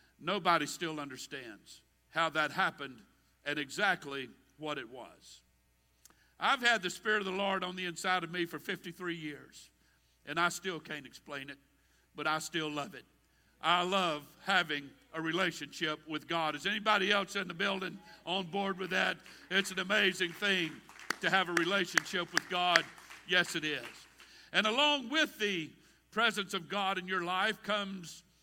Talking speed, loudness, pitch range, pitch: 165 wpm, -33 LUFS, 155-195 Hz, 180 Hz